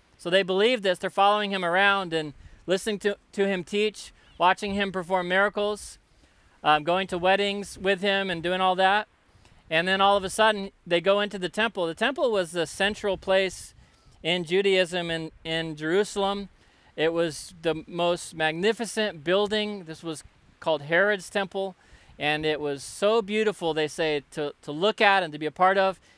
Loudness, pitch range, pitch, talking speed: -25 LUFS, 165-200 Hz, 185 Hz, 180 wpm